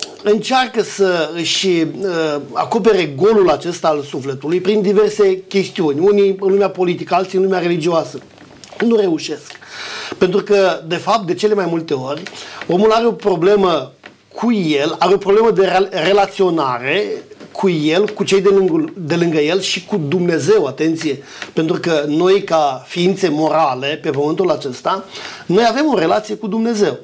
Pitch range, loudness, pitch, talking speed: 165-210 Hz, -15 LUFS, 190 Hz, 150 wpm